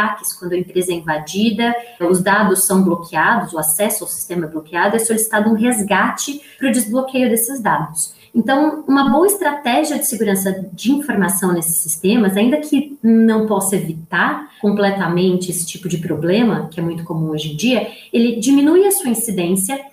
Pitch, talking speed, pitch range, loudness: 205 Hz, 170 wpm, 175-240 Hz, -16 LUFS